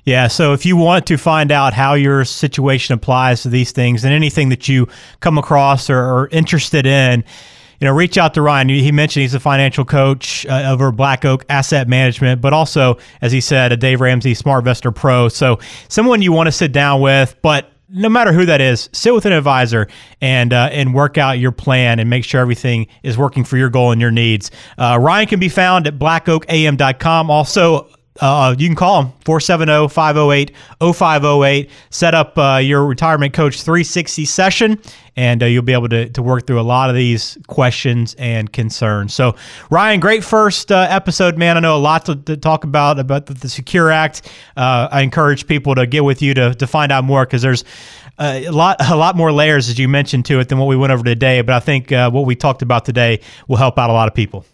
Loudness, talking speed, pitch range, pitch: -13 LUFS, 215 wpm, 125-155 Hz, 135 Hz